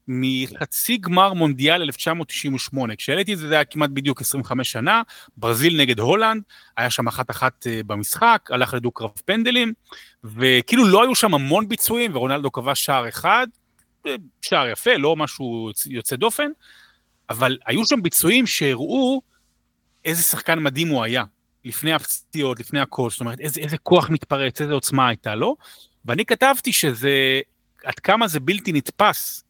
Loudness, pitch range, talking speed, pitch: -20 LUFS, 130-195 Hz, 150 wpm, 145 Hz